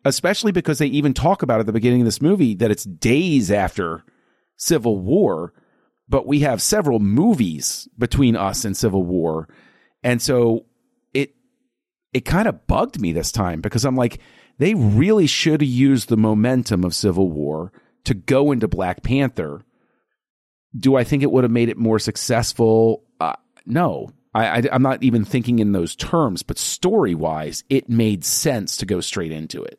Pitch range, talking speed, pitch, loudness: 105-135 Hz, 175 wpm, 120 Hz, -19 LUFS